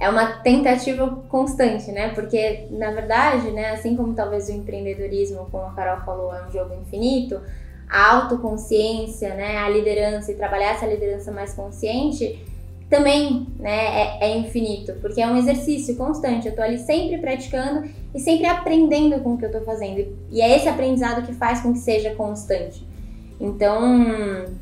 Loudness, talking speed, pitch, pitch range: -21 LUFS, 165 wpm, 220 Hz, 205-250 Hz